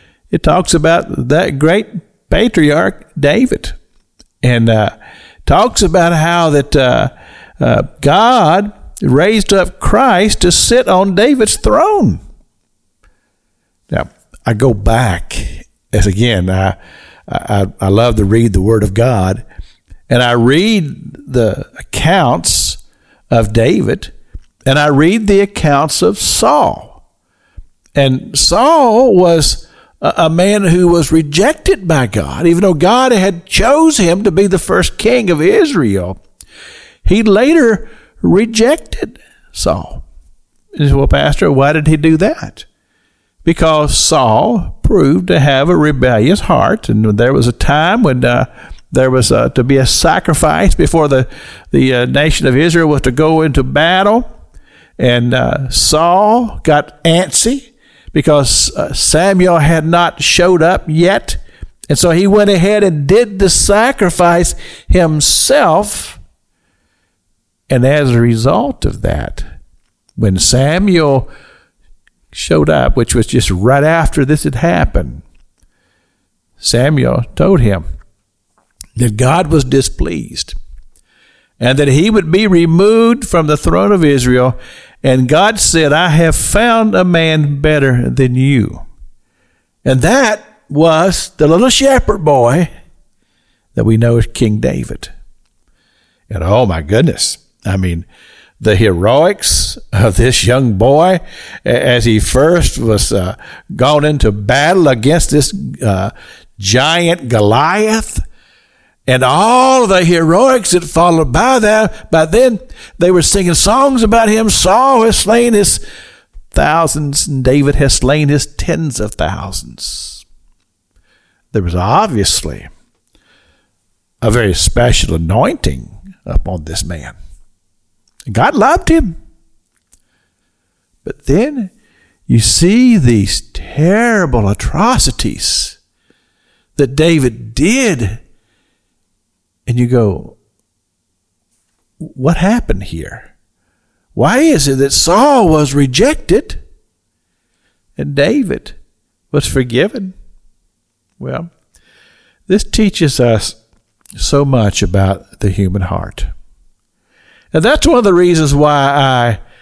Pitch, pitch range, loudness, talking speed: 145 Hz, 110-180 Hz, -11 LUFS, 120 wpm